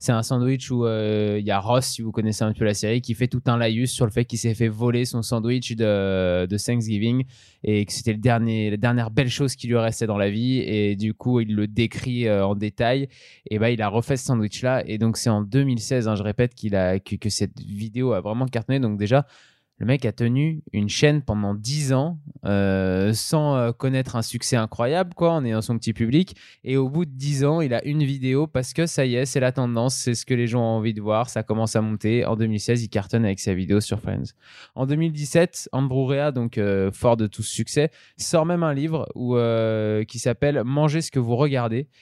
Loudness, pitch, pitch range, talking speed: -23 LUFS, 120 Hz, 110-130 Hz, 240 wpm